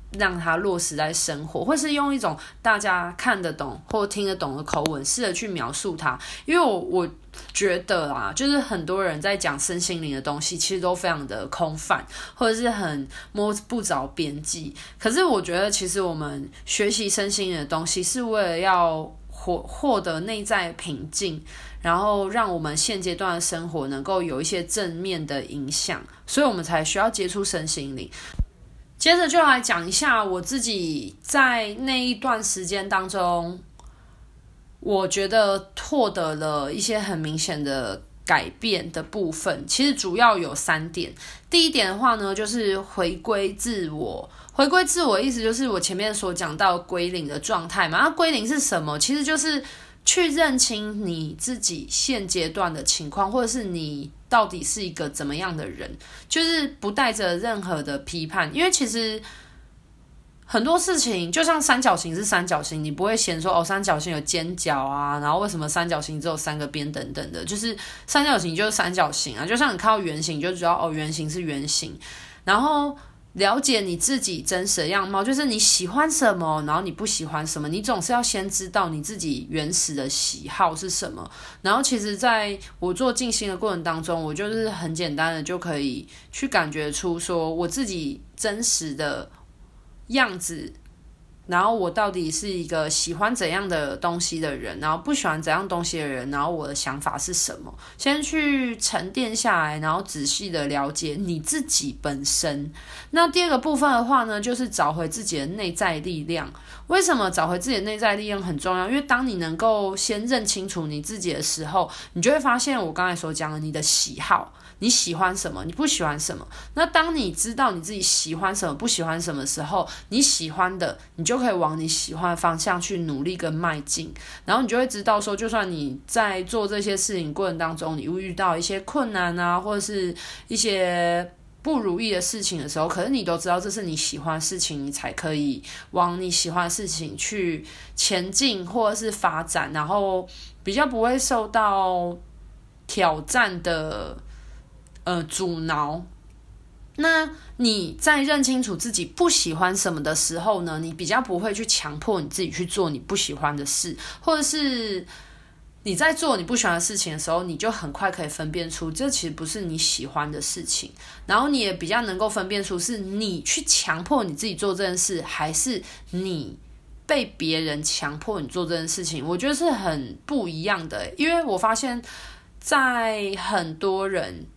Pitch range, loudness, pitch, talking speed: 160-220 Hz, -23 LUFS, 185 Hz, 275 characters per minute